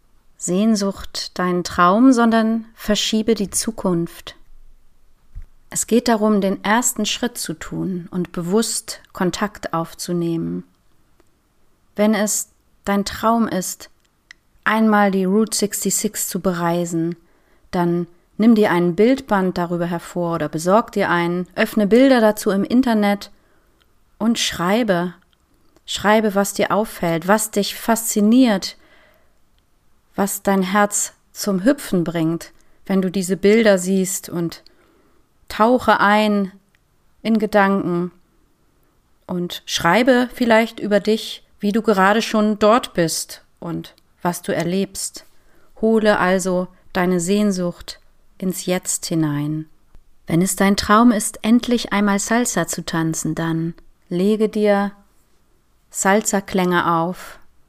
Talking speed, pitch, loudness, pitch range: 115 wpm, 200 Hz, -18 LUFS, 175-220 Hz